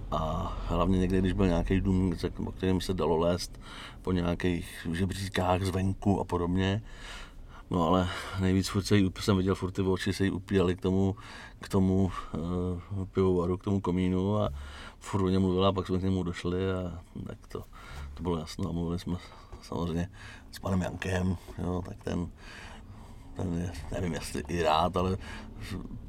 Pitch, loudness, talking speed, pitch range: 90 Hz, -30 LUFS, 165 wpm, 85-95 Hz